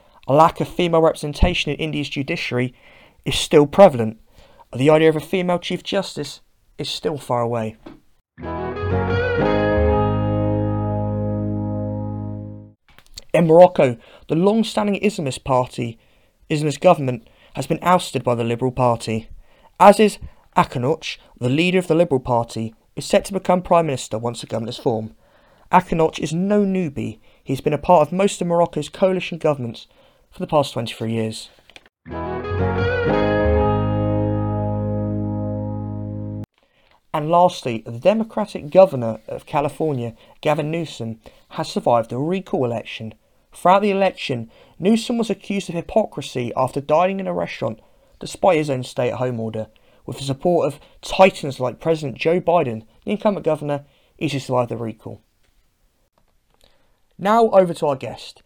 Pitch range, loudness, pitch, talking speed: 110-170 Hz, -20 LUFS, 135 Hz, 135 wpm